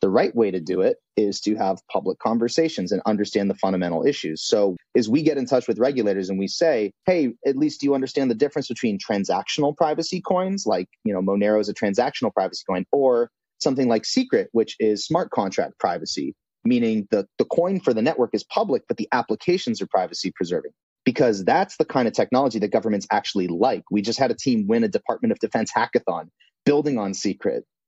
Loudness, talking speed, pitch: -22 LUFS, 205 wpm, 130 Hz